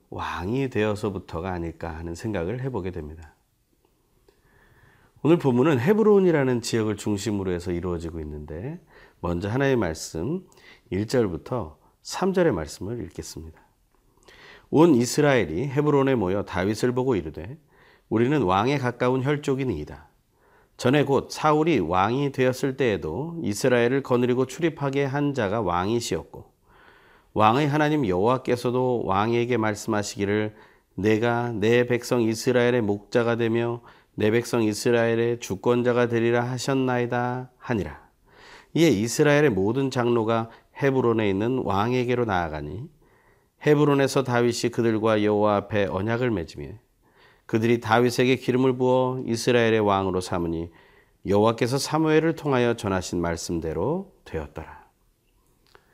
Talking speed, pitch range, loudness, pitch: 315 characters per minute, 100-130 Hz, -24 LUFS, 120 Hz